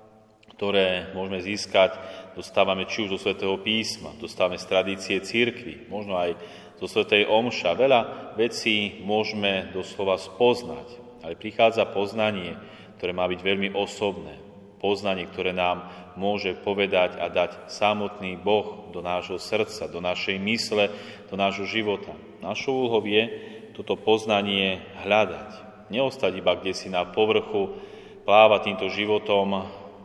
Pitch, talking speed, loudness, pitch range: 100 Hz, 130 wpm, -25 LUFS, 95-105 Hz